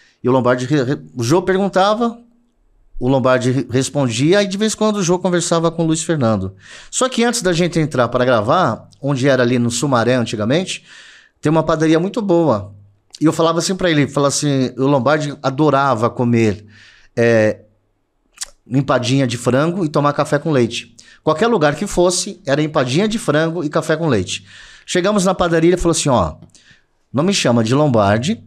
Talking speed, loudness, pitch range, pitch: 185 wpm, -16 LUFS, 125-175 Hz, 145 Hz